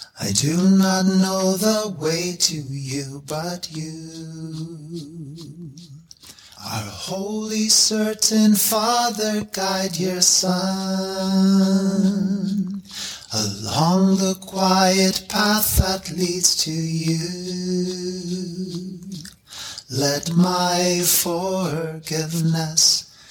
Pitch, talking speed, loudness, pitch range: 180 Hz, 70 wpm, -20 LUFS, 160-190 Hz